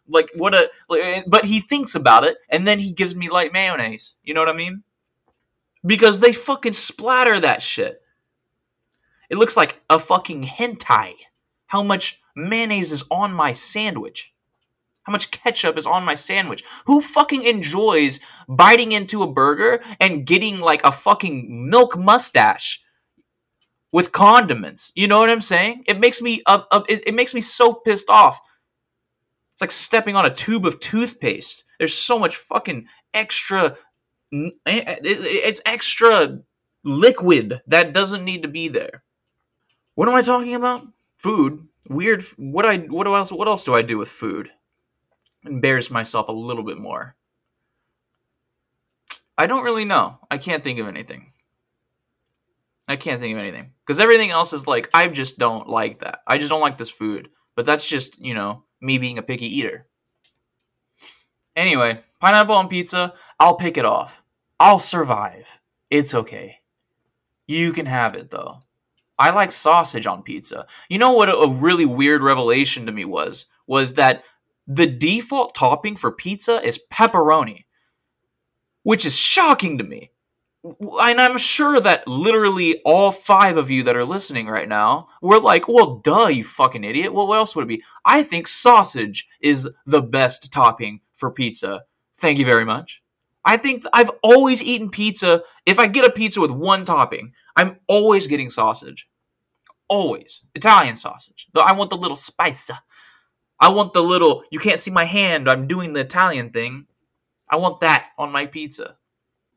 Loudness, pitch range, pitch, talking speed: -17 LUFS, 140-225 Hz, 180 Hz, 165 wpm